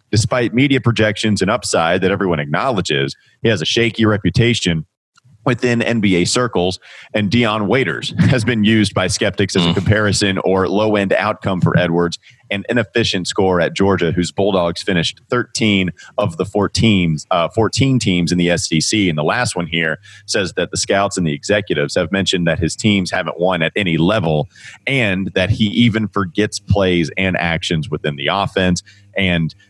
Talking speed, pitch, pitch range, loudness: 175 wpm, 100 Hz, 90-110 Hz, -16 LUFS